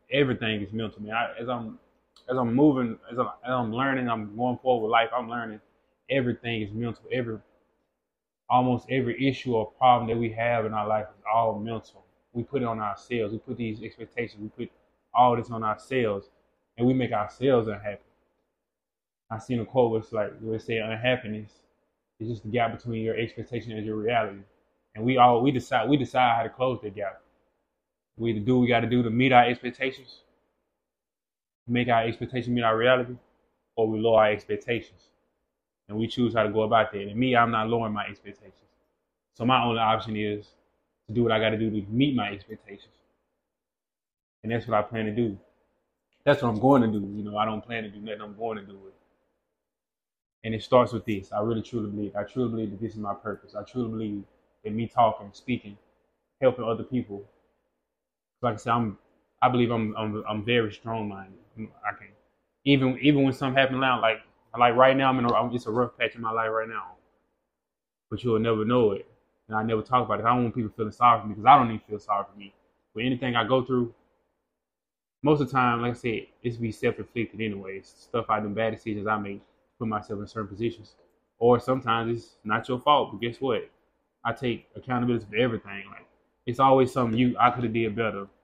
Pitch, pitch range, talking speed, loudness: 115 Hz, 105-125 Hz, 210 wpm, -26 LUFS